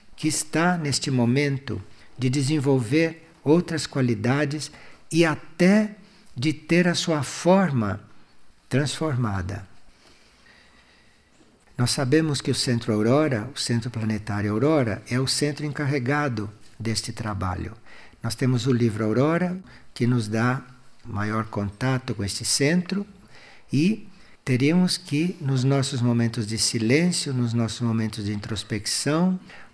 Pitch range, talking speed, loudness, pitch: 115-155 Hz, 115 wpm, -24 LUFS, 130 Hz